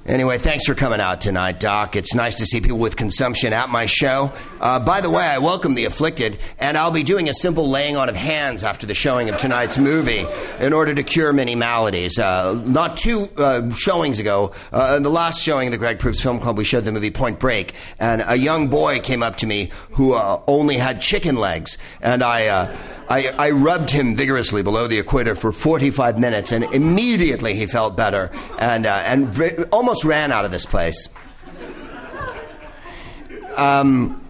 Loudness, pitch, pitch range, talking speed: -18 LUFS, 130 Hz, 115-145 Hz, 200 wpm